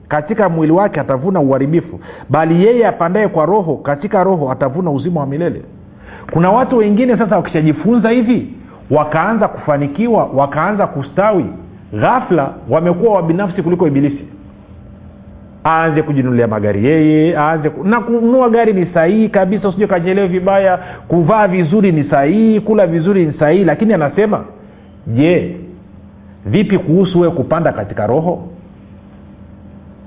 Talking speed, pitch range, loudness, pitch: 120 wpm, 140-200 Hz, -13 LUFS, 165 Hz